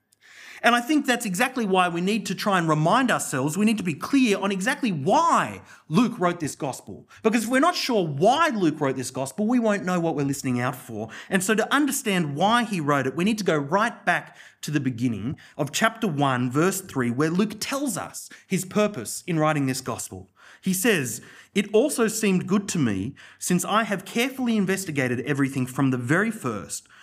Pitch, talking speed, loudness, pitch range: 190 Hz, 205 wpm, -24 LUFS, 145-225 Hz